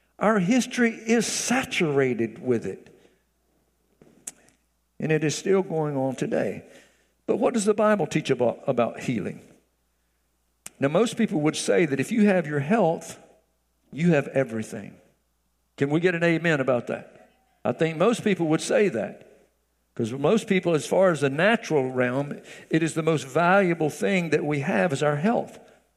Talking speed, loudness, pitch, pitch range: 165 wpm, -24 LUFS, 155 Hz, 130-195 Hz